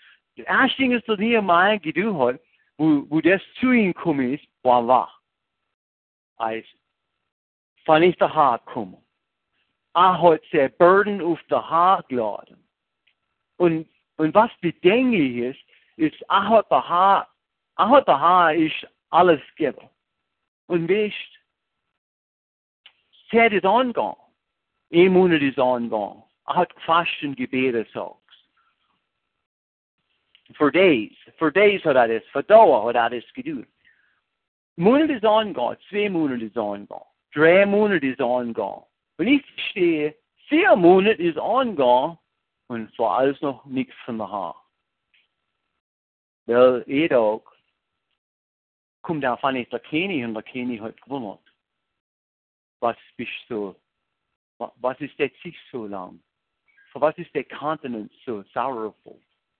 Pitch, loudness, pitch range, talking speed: 155 Hz, -20 LUFS, 120-200 Hz, 105 wpm